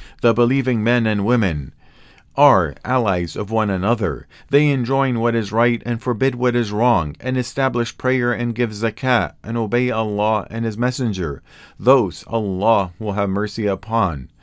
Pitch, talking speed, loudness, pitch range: 115 Hz, 160 wpm, -19 LUFS, 105-125 Hz